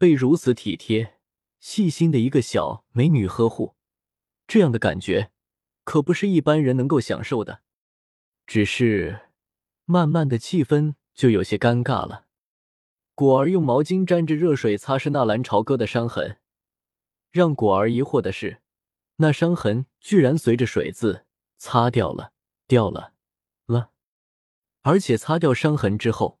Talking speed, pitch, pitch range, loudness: 210 characters per minute, 130 Hz, 115-160 Hz, -21 LUFS